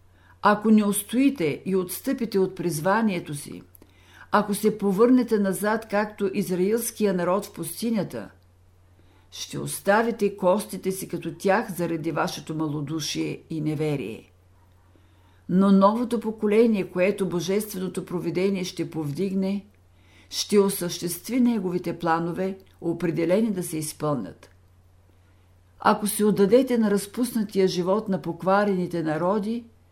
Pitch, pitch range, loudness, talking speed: 185 Hz, 155-205 Hz, -24 LUFS, 105 wpm